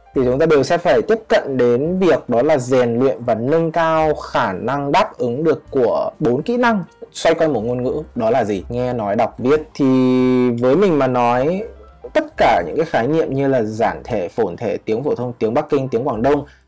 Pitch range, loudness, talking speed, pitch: 125-165 Hz, -17 LUFS, 230 wpm, 135 Hz